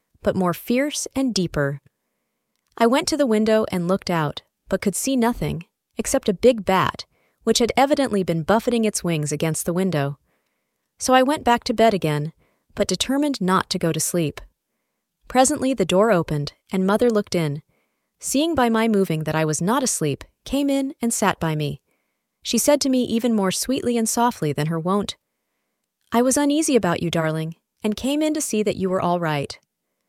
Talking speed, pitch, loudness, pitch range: 190 wpm, 210 Hz, -21 LUFS, 170-245 Hz